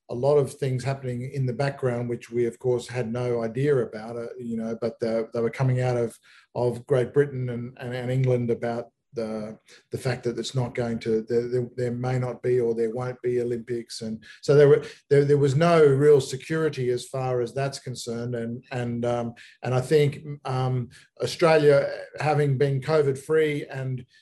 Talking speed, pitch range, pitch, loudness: 200 wpm, 120-140 Hz, 125 Hz, -25 LUFS